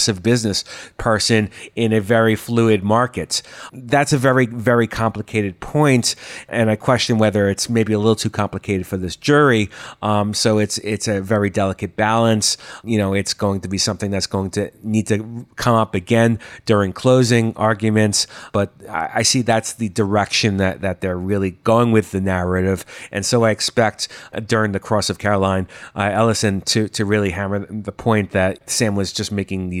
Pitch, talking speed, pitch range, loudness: 110 Hz, 185 wpm, 100-115 Hz, -18 LUFS